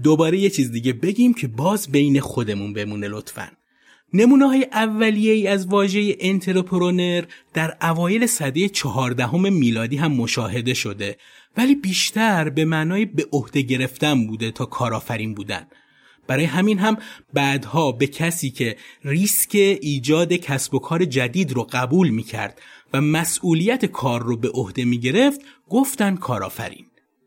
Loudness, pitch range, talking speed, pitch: -20 LUFS, 125-195 Hz, 140 wpm, 155 Hz